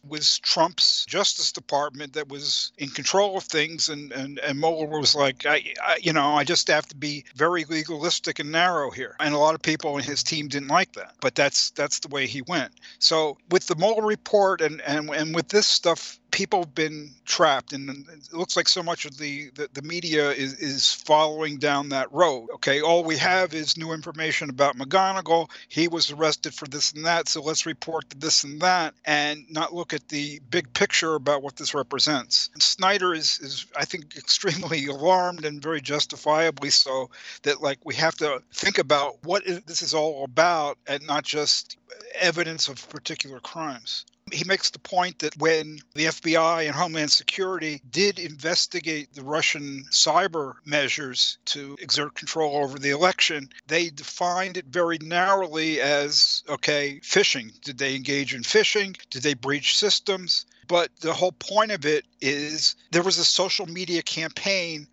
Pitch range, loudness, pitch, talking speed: 145-175 Hz, -23 LUFS, 155 Hz, 185 wpm